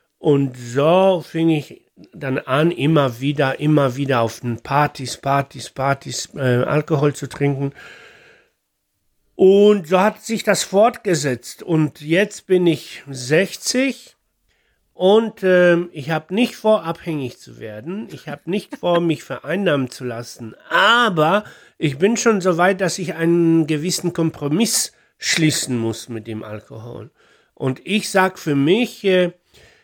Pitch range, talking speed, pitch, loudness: 140-185 Hz, 140 wpm, 160 Hz, -18 LUFS